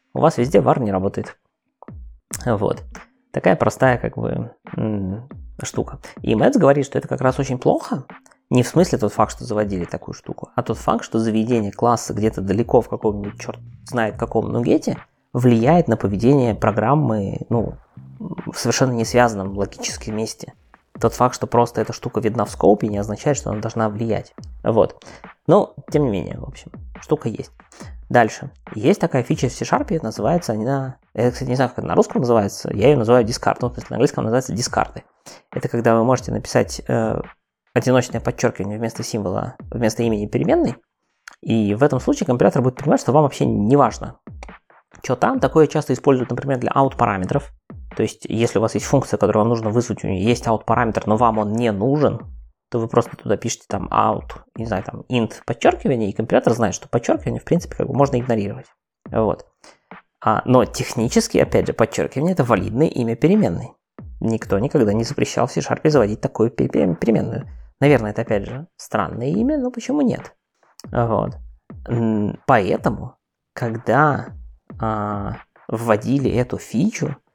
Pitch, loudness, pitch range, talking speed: 115 Hz, -20 LUFS, 105-130 Hz, 170 wpm